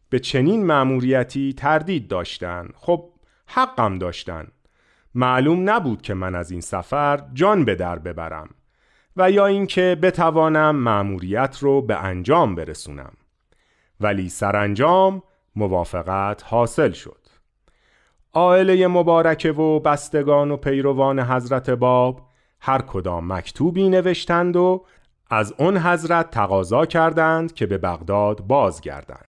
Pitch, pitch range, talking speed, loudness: 135 Hz, 100-165 Hz, 115 wpm, -19 LUFS